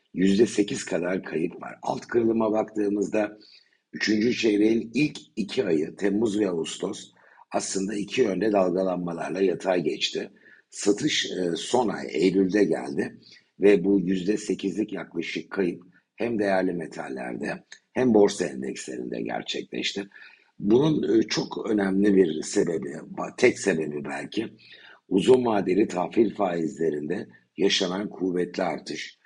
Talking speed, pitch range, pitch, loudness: 110 wpm, 90-105 Hz, 100 Hz, -25 LUFS